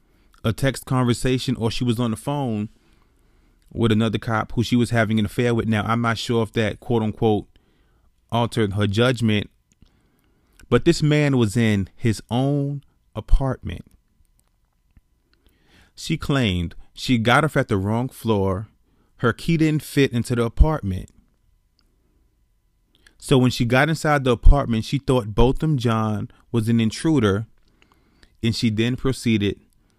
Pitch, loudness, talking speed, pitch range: 115 Hz, -21 LUFS, 145 wpm, 105-130 Hz